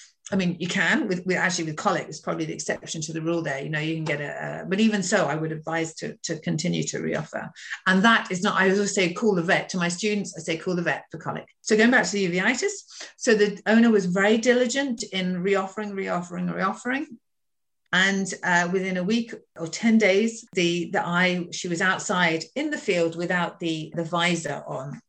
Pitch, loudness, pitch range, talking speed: 185 Hz, -24 LUFS, 170-210 Hz, 220 wpm